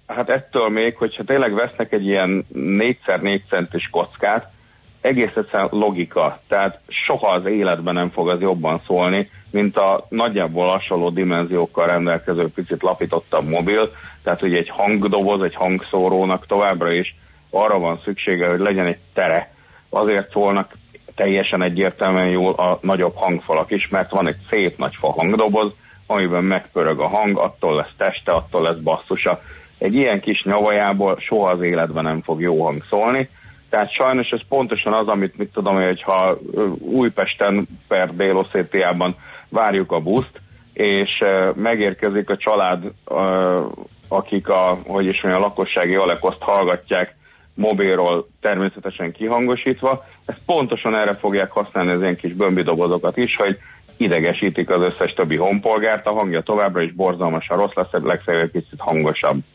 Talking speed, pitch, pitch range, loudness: 145 wpm, 95 Hz, 90-105 Hz, -19 LUFS